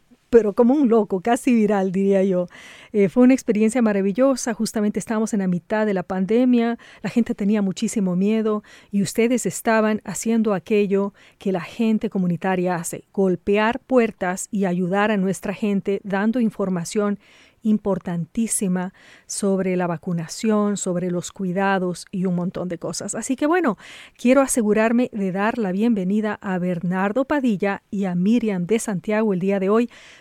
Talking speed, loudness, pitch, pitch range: 155 wpm, -21 LUFS, 205 Hz, 190-225 Hz